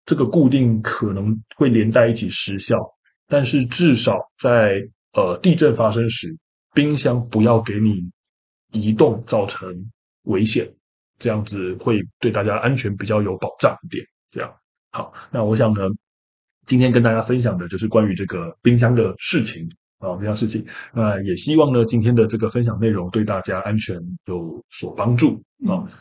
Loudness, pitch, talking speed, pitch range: -19 LUFS, 110 Hz, 245 characters per minute, 100-120 Hz